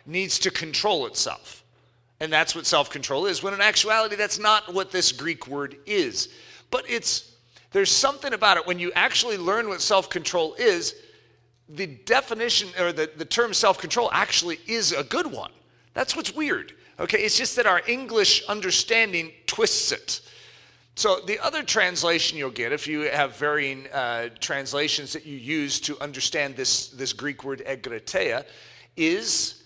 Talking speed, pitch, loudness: 160 wpm, 180 Hz, -23 LUFS